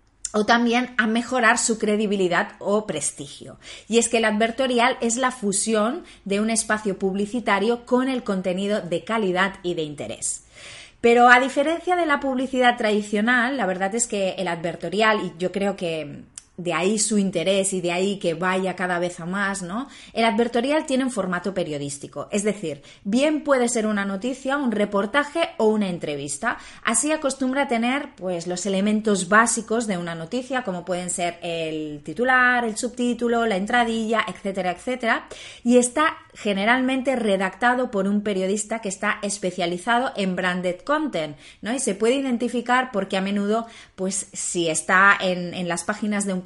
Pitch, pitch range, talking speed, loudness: 210 Hz, 185-245 Hz, 165 wpm, -22 LUFS